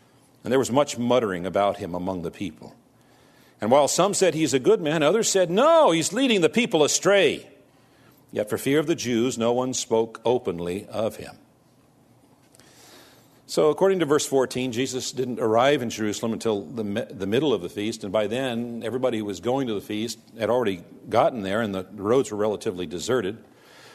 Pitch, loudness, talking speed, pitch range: 125 Hz, -23 LUFS, 190 wpm, 110-150 Hz